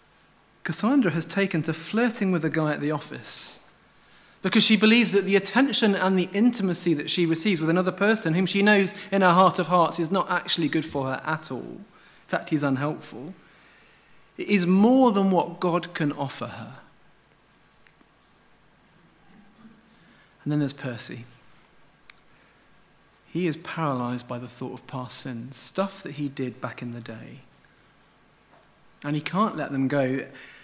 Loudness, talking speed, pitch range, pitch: -24 LUFS, 160 wpm, 140-195 Hz, 165 Hz